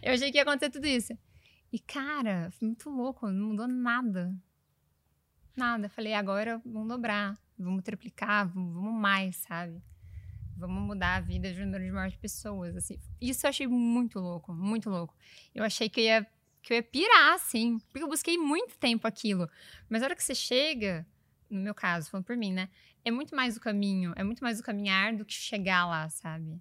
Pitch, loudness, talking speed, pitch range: 215 Hz, -30 LUFS, 195 wpm, 185-240 Hz